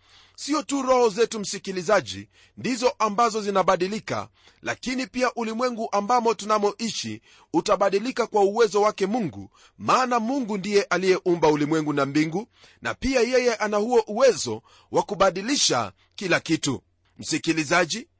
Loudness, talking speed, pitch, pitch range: -23 LUFS, 115 wpm, 205 Hz, 170-235 Hz